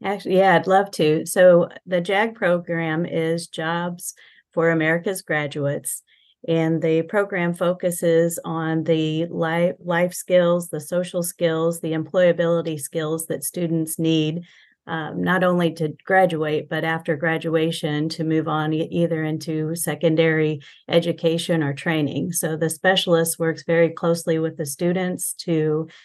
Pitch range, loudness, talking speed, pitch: 160-175 Hz, -21 LUFS, 135 wpm, 165 Hz